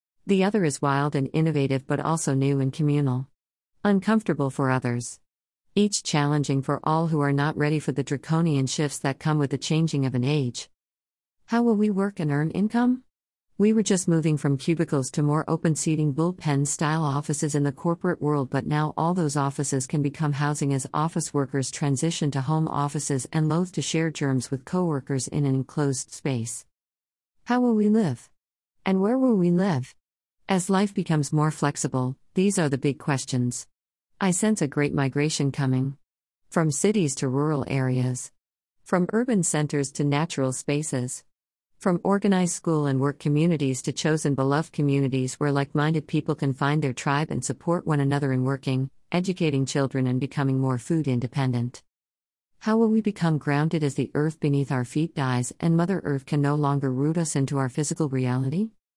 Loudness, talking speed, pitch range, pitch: -25 LUFS, 180 wpm, 135-165 Hz, 145 Hz